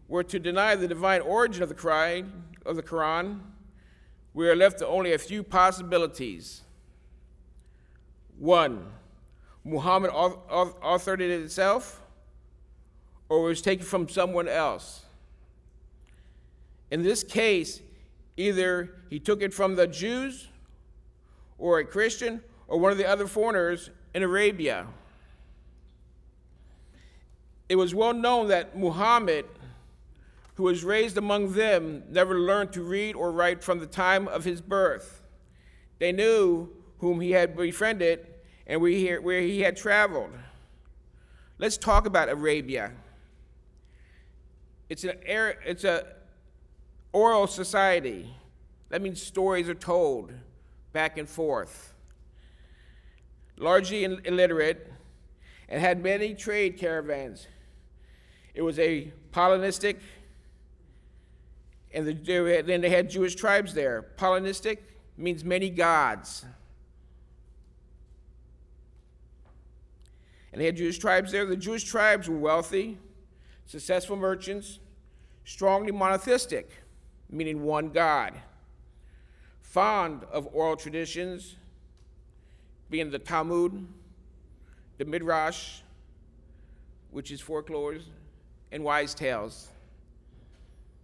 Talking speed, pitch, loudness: 105 wpm, 160 Hz, -27 LUFS